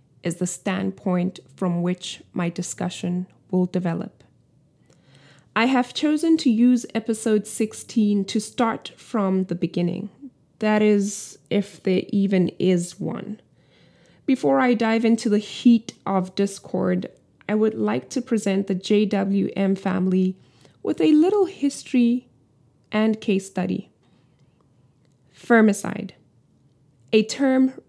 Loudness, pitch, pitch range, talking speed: -22 LUFS, 195 Hz, 180-225 Hz, 115 wpm